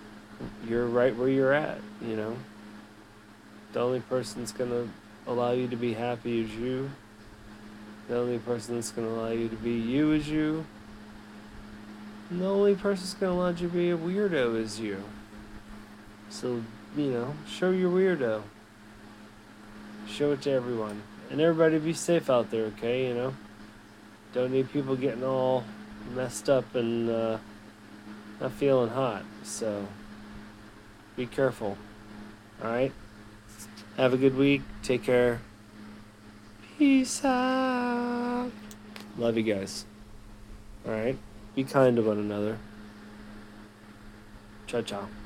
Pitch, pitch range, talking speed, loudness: 110 Hz, 105-130 Hz, 135 wpm, -29 LUFS